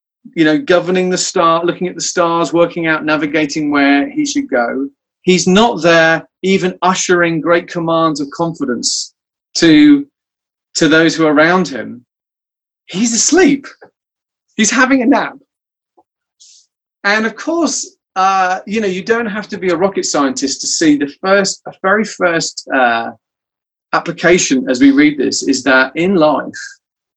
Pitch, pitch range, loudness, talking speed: 180 Hz, 160-220 Hz, -13 LUFS, 150 wpm